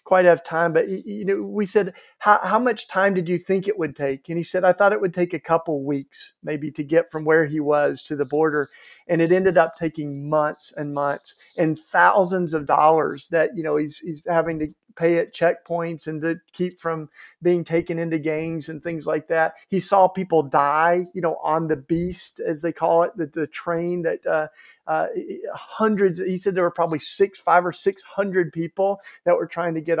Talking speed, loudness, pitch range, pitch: 220 wpm, -22 LUFS, 155-185 Hz, 170 Hz